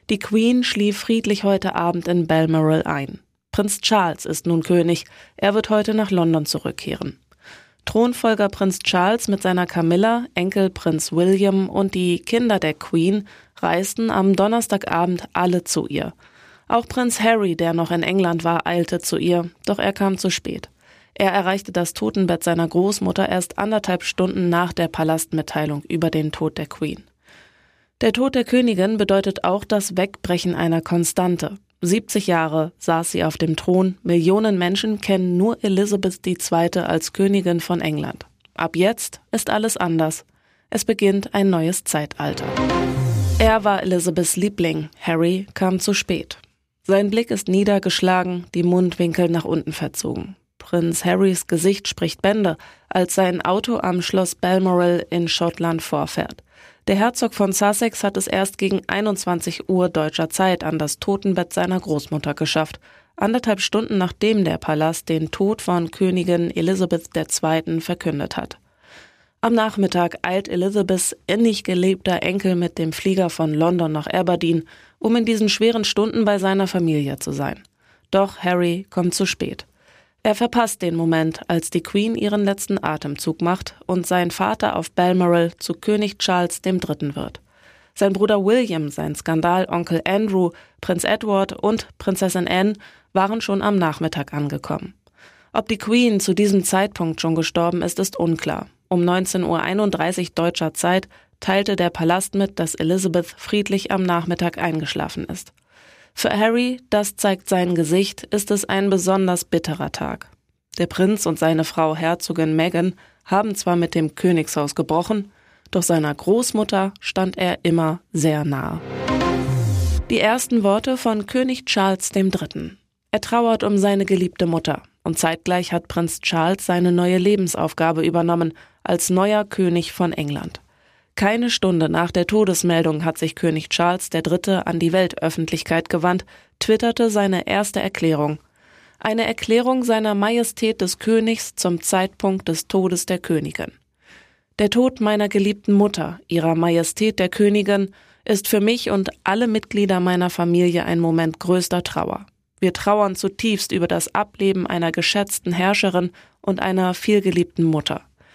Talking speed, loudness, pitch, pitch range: 145 wpm, -20 LUFS, 185 Hz, 170-200 Hz